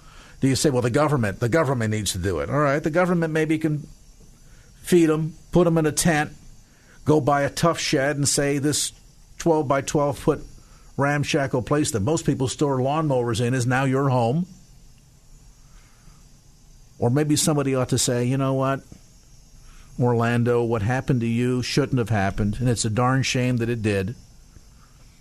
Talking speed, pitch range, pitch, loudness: 175 wpm, 125-150 Hz, 135 Hz, -22 LUFS